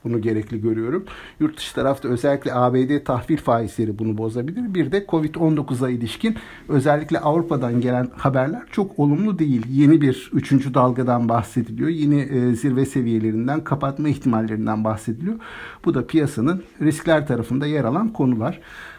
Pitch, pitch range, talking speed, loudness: 135 Hz, 120-155 Hz, 135 wpm, -21 LUFS